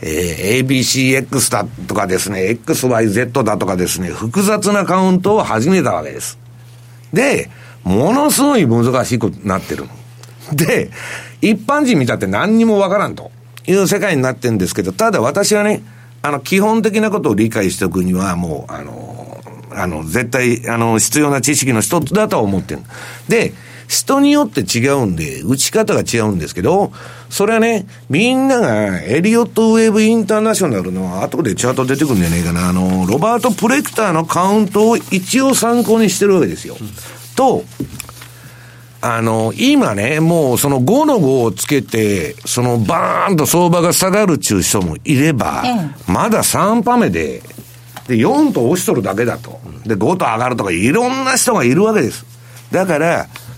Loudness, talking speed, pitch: -14 LUFS, 325 characters per minute, 135 Hz